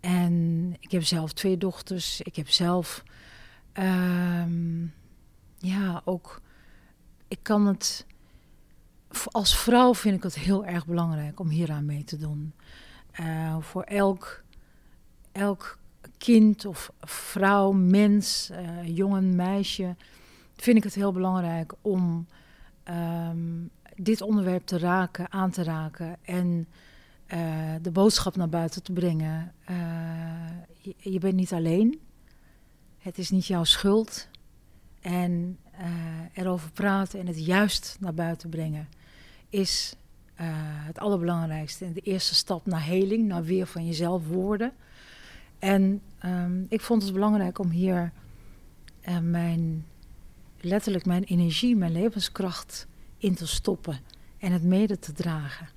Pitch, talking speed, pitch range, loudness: 180 Hz, 125 wpm, 165-195 Hz, -27 LUFS